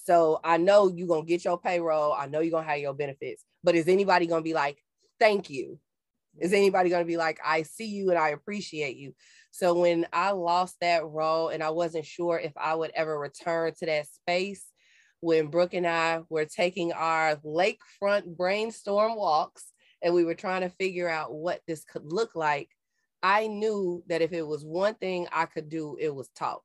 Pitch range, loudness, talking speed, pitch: 160-185 Hz, -27 LUFS, 210 wpm, 170 Hz